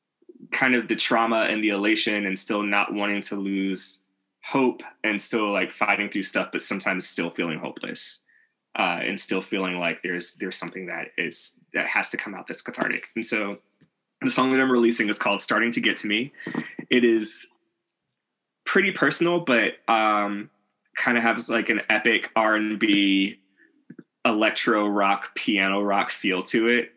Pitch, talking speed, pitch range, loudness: 105 Hz, 170 wpm, 100-120 Hz, -23 LUFS